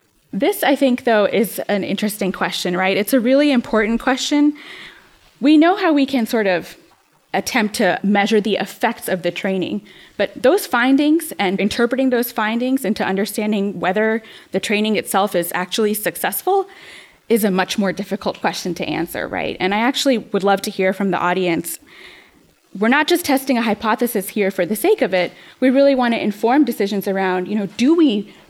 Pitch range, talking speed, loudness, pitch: 195-255 Hz, 185 wpm, -18 LUFS, 215 Hz